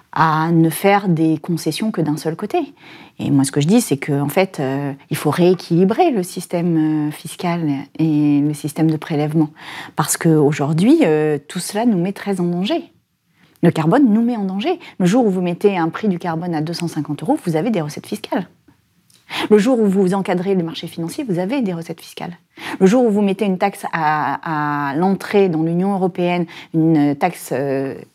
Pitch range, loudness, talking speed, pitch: 155-195 Hz, -18 LUFS, 195 wpm, 170 Hz